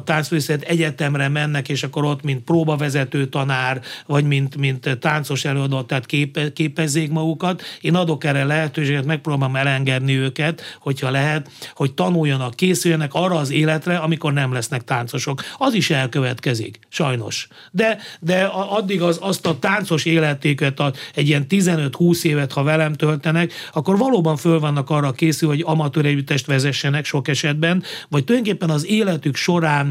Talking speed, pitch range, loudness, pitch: 150 wpm, 140-165 Hz, -19 LUFS, 150 Hz